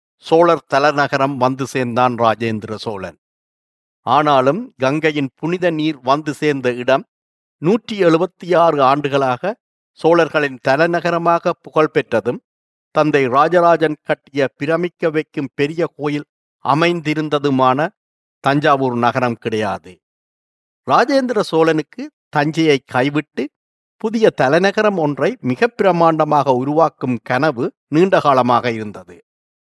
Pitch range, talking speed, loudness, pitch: 130-165 Hz, 90 wpm, -16 LUFS, 150 Hz